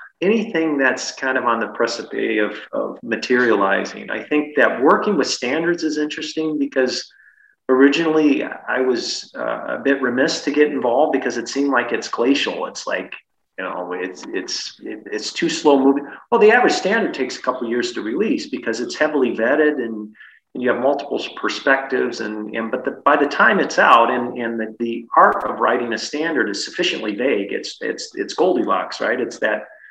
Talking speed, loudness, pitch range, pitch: 190 wpm, -19 LUFS, 120-155 Hz, 135 Hz